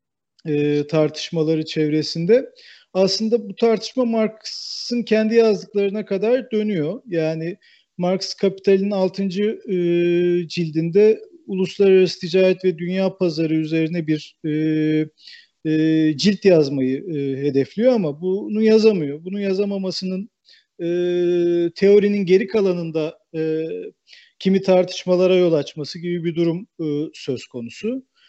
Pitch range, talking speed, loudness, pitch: 160-205 Hz, 90 wpm, -20 LUFS, 185 Hz